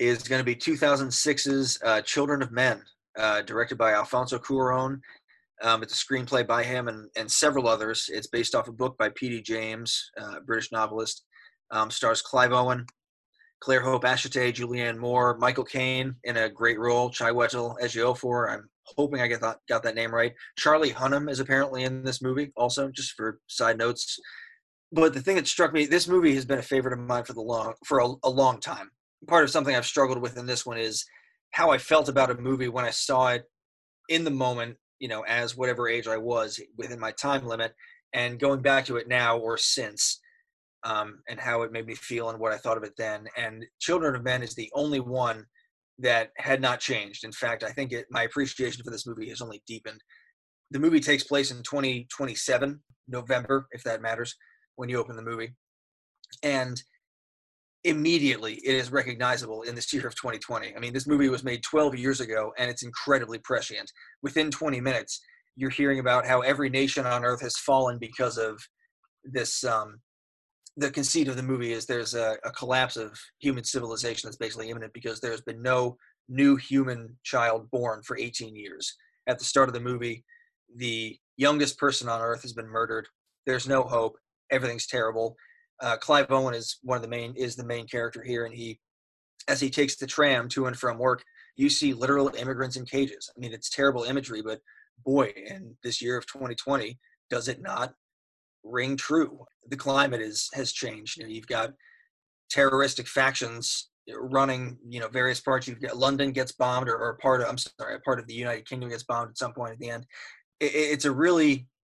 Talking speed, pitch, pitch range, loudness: 200 wpm, 125 Hz, 115-135 Hz, -27 LUFS